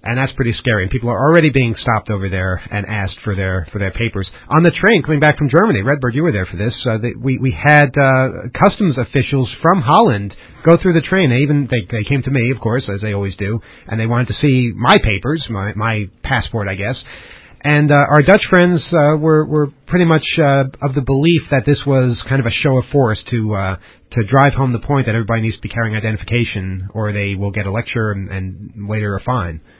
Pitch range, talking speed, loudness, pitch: 105-145 Hz, 240 wpm, -15 LUFS, 120 Hz